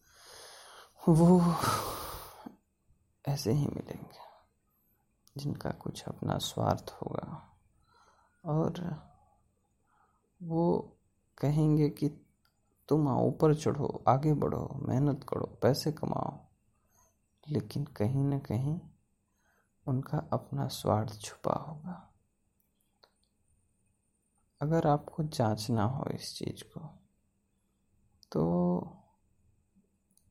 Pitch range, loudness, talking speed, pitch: 105-150 Hz, -32 LUFS, 80 wpm, 140 Hz